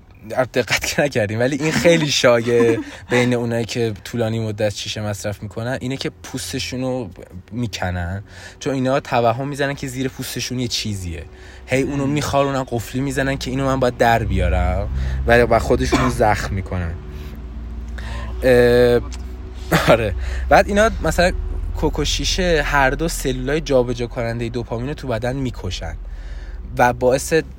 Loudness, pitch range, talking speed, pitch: -19 LUFS, 90-130 Hz, 140 wpm, 120 Hz